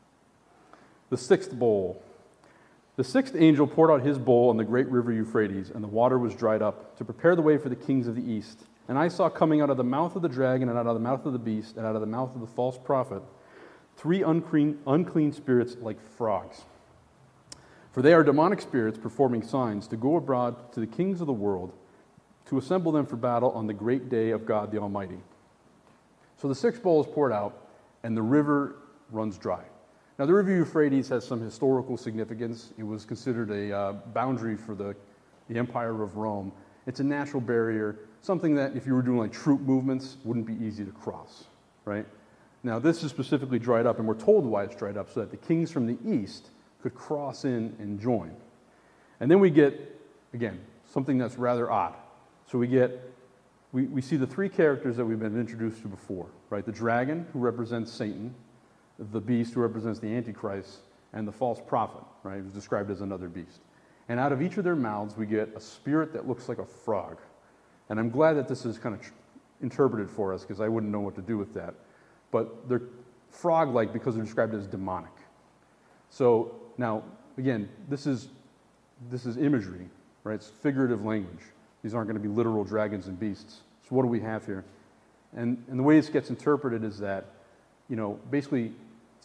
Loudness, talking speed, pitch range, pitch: -28 LUFS, 200 wpm, 110-135 Hz, 120 Hz